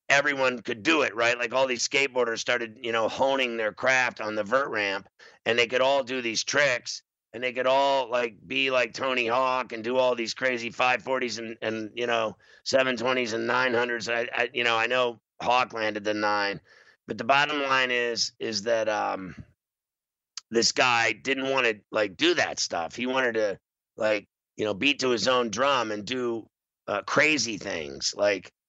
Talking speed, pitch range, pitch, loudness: 200 wpm, 115-130 Hz, 120 Hz, -25 LUFS